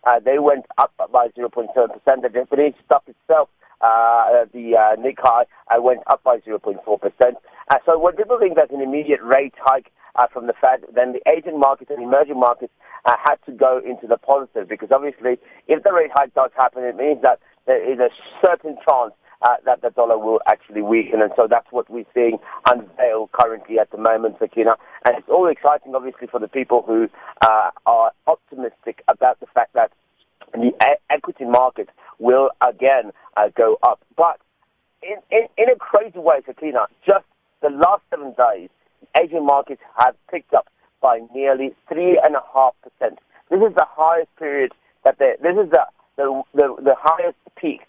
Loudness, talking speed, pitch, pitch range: -18 LUFS, 185 wpm, 135 Hz, 120-155 Hz